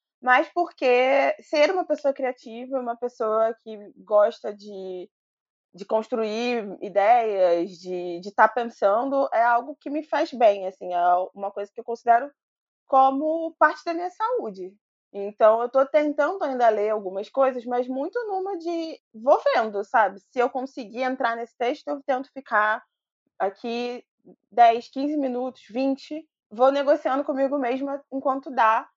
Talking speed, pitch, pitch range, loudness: 150 wpm, 245 Hz, 215-285 Hz, -24 LUFS